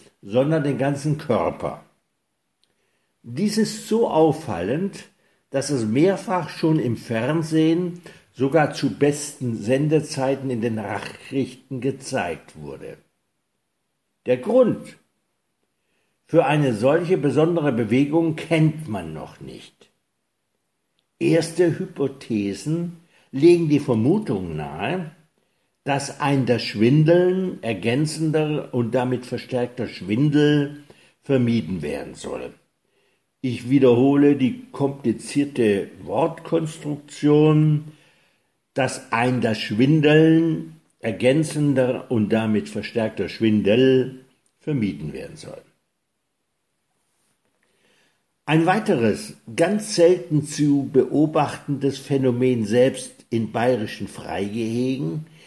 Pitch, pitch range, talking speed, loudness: 140 Hz, 125-160 Hz, 85 wpm, -21 LUFS